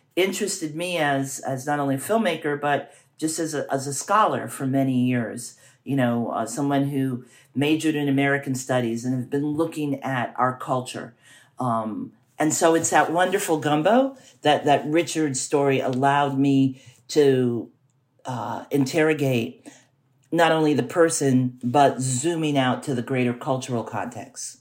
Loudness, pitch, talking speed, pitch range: -23 LUFS, 135 Hz, 150 wpm, 130-150 Hz